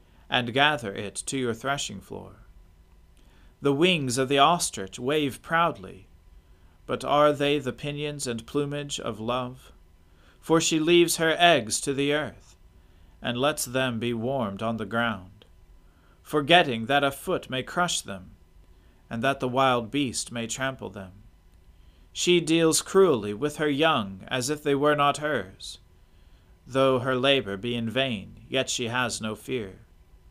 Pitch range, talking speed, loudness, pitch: 90-145 Hz, 150 wpm, -25 LUFS, 120 Hz